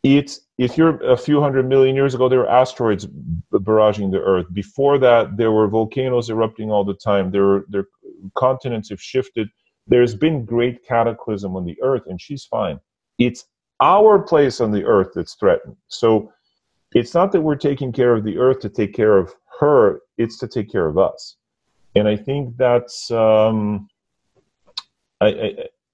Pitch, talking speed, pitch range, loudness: 120 Hz, 175 wpm, 105-135 Hz, -18 LUFS